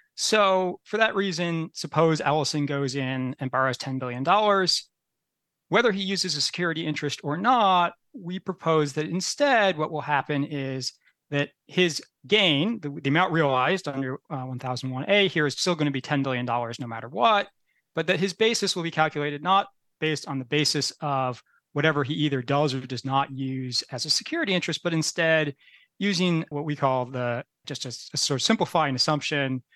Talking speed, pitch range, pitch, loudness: 175 wpm, 135-180 Hz, 150 Hz, -25 LUFS